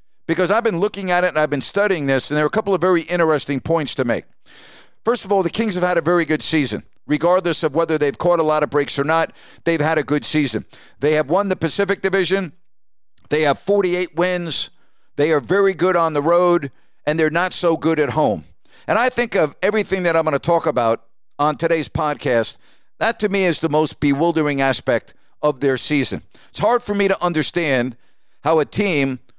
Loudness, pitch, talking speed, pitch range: -19 LUFS, 160 Hz, 220 wpm, 145-180 Hz